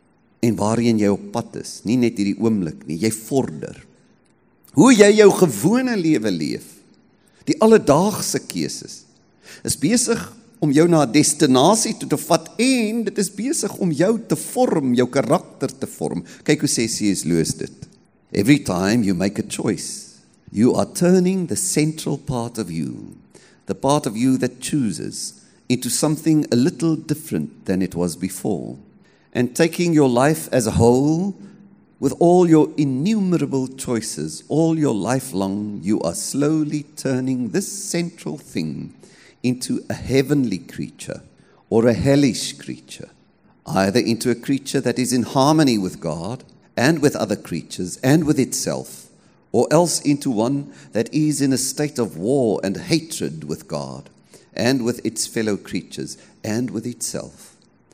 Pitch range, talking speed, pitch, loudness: 115-170 Hz, 155 wpm, 140 Hz, -19 LUFS